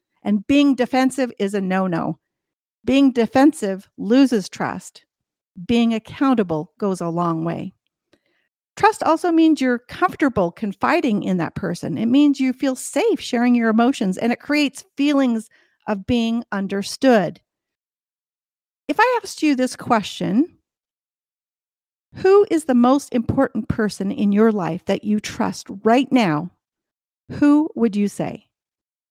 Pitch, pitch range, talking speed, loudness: 235 Hz, 205-275 Hz, 135 wpm, -19 LUFS